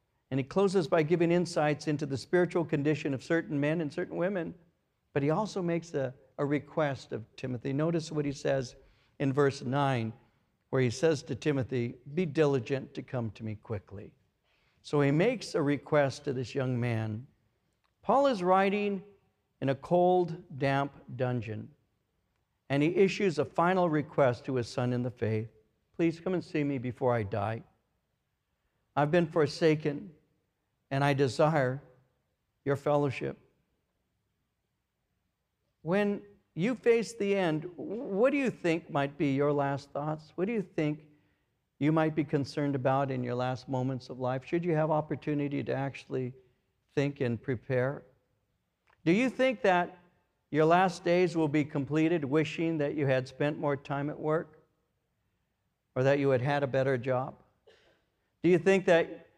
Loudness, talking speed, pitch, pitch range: -30 LUFS, 160 wpm, 145 Hz, 130-165 Hz